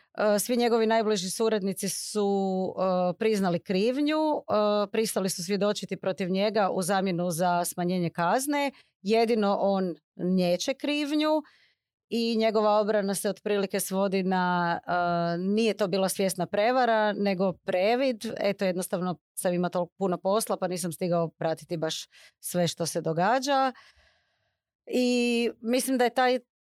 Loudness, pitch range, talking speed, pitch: -27 LUFS, 180-225 Hz, 135 wpm, 200 Hz